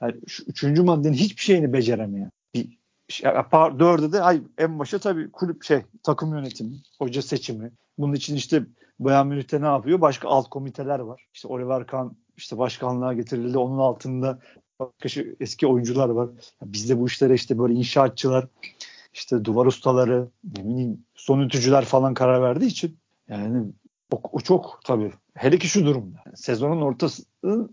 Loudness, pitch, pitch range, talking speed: -23 LUFS, 135 Hz, 125-150 Hz, 160 wpm